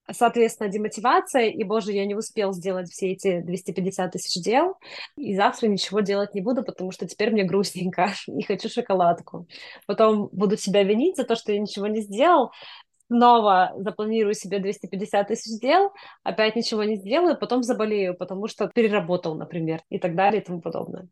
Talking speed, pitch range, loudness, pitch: 170 wpm, 190-225 Hz, -23 LUFS, 210 Hz